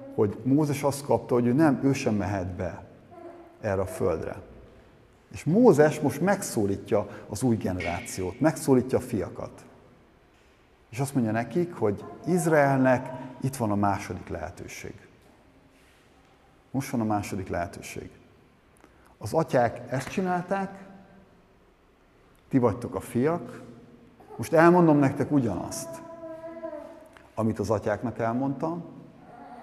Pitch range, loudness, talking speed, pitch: 110-165 Hz, -26 LUFS, 110 wpm, 130 Hz